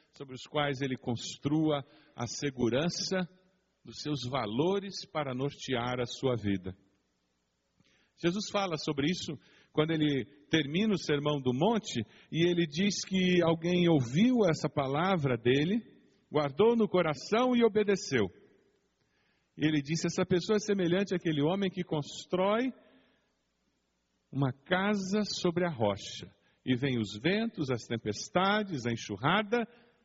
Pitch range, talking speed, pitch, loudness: 130-190 Hz, 125 wpm, 155 Hz, -31 LUFS